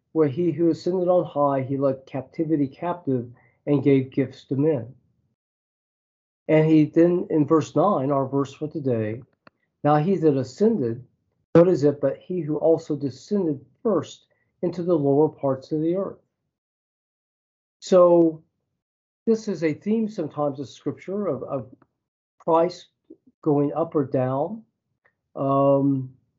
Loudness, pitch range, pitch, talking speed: -23 LUFS, 135-170 Hz, 150 Hz, 140 wpm